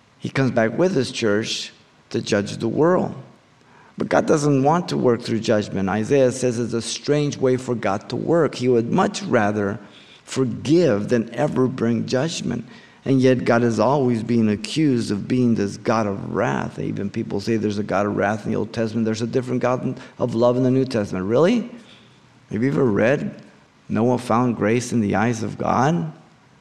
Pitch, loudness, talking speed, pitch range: 120 Hz, -21 LUFS, 190 wpm, 110-130 Hz